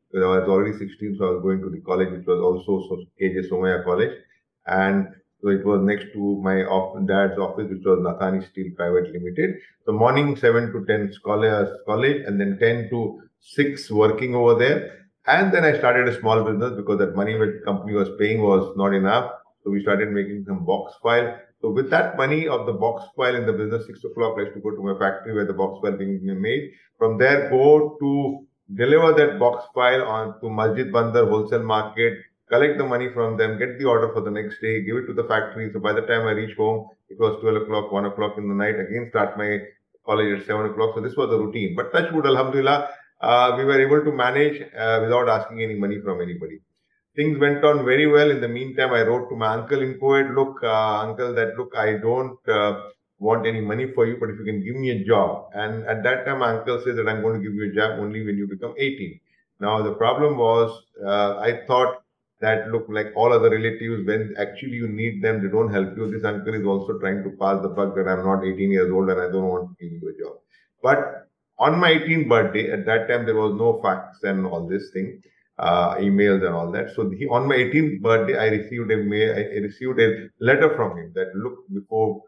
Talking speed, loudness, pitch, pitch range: 230 wpm, -21 LUFS, 110 Hz, 100-125 Hz